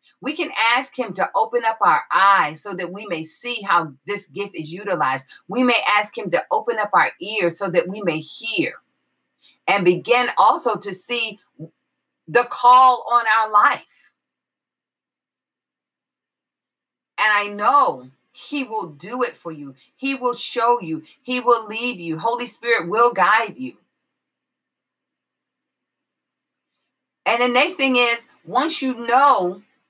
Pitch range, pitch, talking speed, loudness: 190-250 Hz, 230 Hz, 145 wpm, -19 LUFS